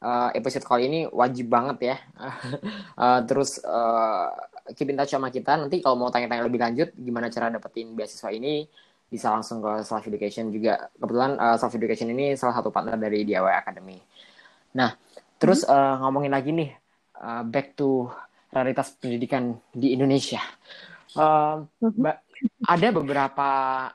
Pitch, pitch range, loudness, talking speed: 130 Hz, 115-140 Hz, -25 LUFS, 145 wpm